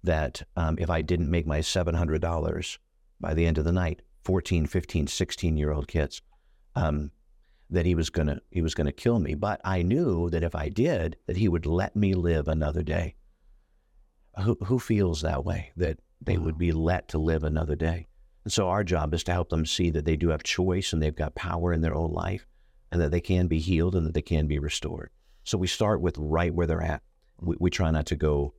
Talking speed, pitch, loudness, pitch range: 230 wpm, 85 Hz, -28 LUFS, 75-90 Hz